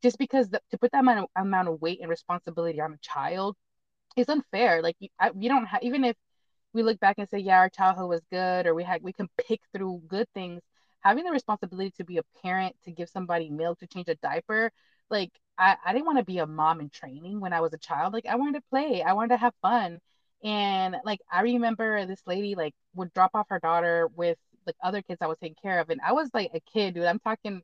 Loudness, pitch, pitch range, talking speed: -27 LUFS, 190 Hz, 170-230 Hz, 250 wpm